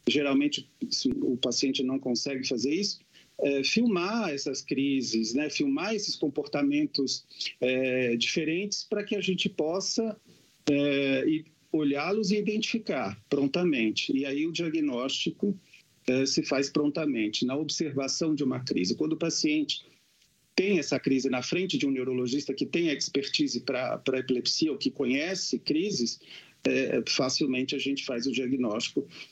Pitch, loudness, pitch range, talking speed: 145 Hz, -28 LUFS, 135-190 Hz, 145 wpm